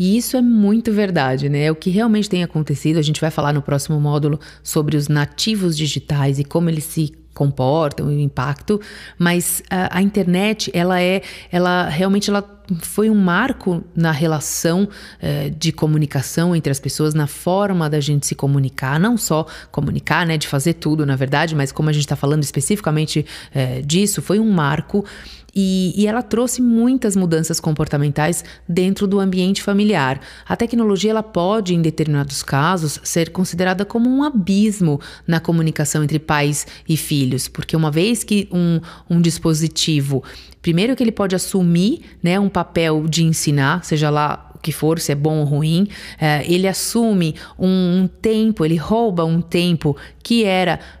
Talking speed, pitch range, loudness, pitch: 170 wpm, 150-195 Hz, -18 LUFS, 165 Hz